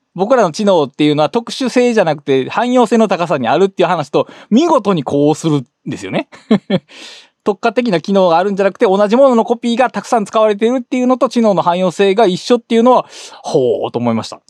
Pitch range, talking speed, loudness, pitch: 175-240 Hz, 445 characters per minute, -13 LUFS, 210 Hz